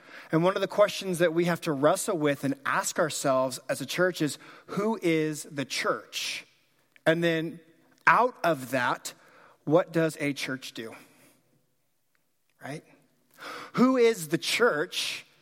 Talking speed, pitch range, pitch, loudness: 145 wpm, 145-185 Hz, 165 Hz, -27 LUFS